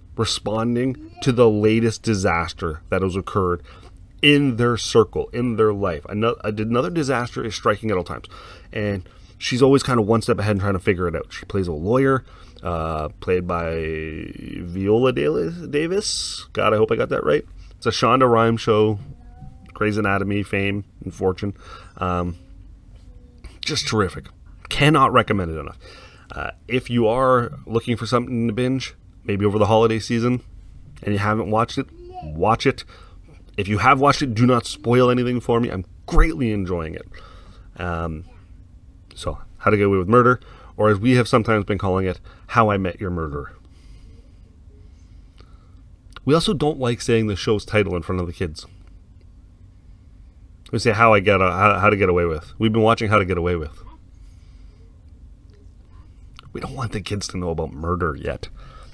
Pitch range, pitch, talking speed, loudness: 90-115 Hz, 100 Hz, 170 wpm, -20 LUFS